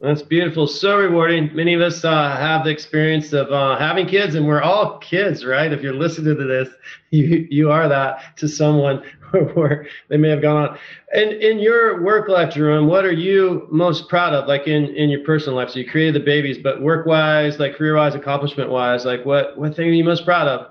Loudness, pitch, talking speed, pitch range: -17 LUFS, 155 Hz, 225 wpm, 145-170 Hz